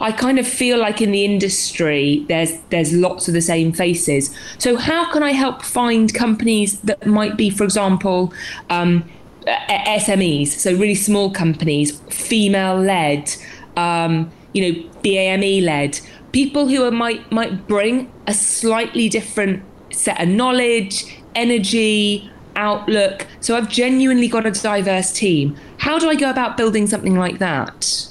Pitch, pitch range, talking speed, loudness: 205 Hz, 175-230 Hz, 150 wpm, -17 LUFS